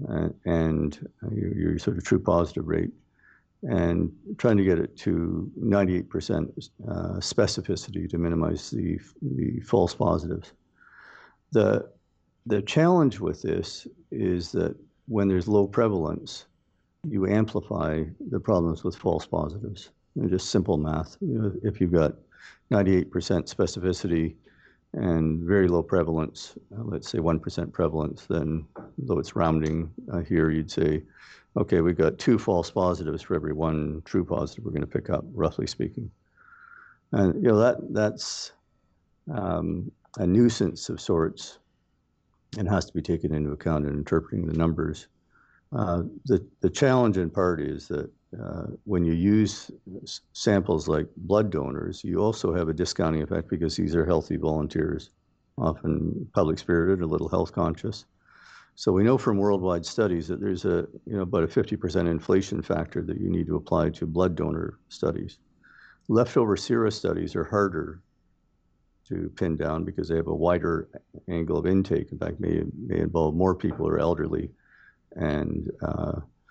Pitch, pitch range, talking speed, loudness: 85 Hz, 80-100 Hz, 155 wpm, -26 LUFS